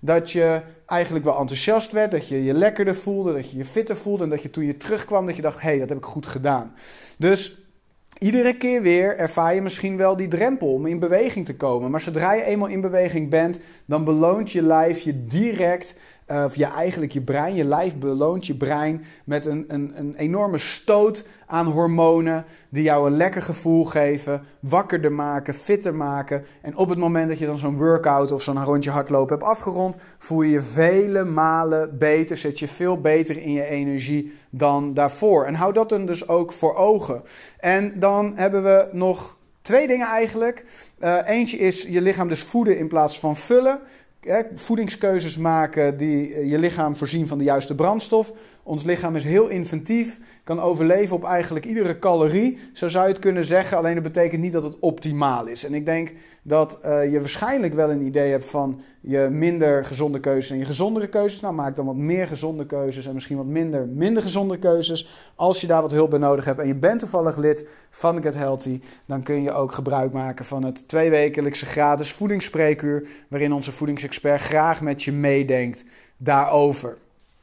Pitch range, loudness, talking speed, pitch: 145-185 Hz, -21 LUFS, 195 wpm, 160 Hz